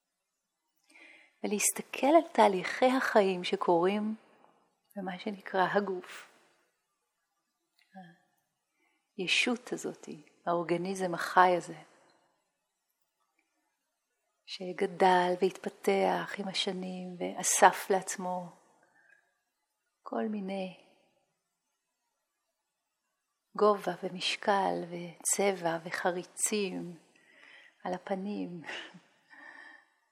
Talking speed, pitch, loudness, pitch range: 55 wpm, 195 Hz, -30 LUFS, 180-210 Hz